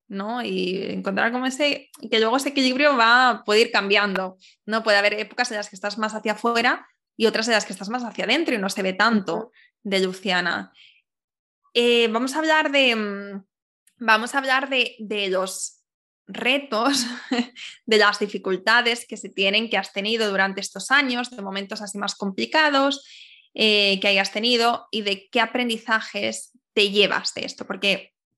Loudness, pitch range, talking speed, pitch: -21 LUFS, 200-245 Hz, 175 wpm, 220 Hz